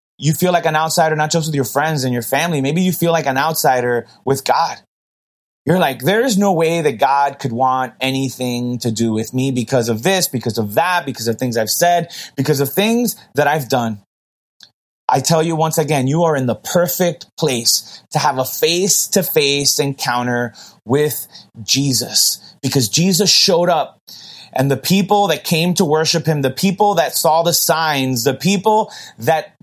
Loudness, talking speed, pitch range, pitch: -16 LUFS, 190 wpm, 130-170 Hz, 145 Hz